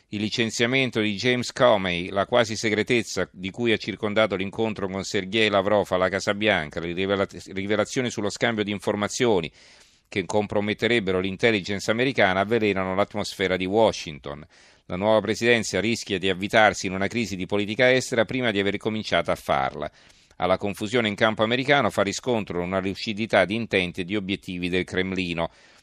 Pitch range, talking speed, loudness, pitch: 95-110 Hz, 160 wpm, -24 LUFS, 105 Hz